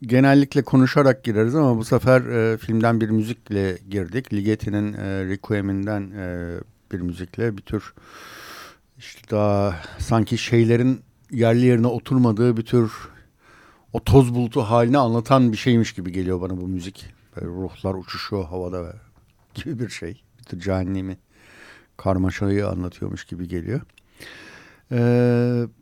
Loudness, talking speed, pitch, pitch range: -21 LUFS, 130 wpm, 110 Hz, 95-120 Hz